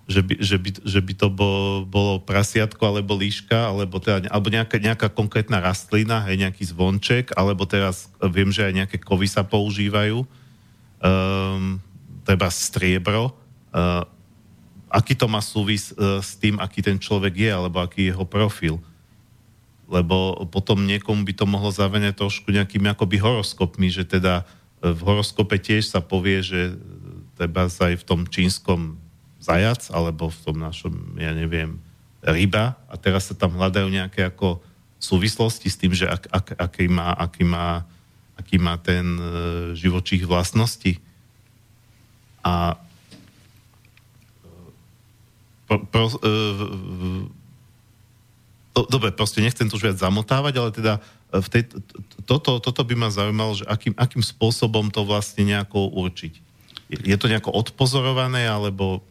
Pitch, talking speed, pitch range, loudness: 100 Hz, 145 wpm, 95-110 Hz, -22 LUFS